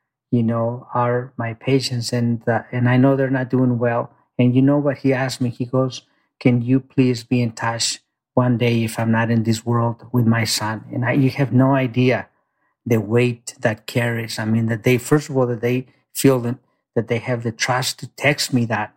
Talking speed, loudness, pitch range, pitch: 220 wpm, -20 LUFS, 115-130 Hz, 125 Hz